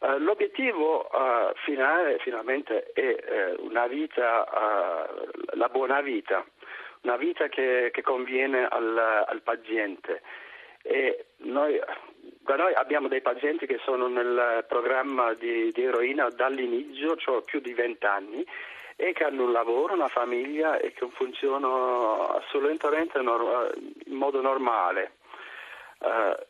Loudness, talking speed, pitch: -27 LUFS, 120 wpm, 335 Hz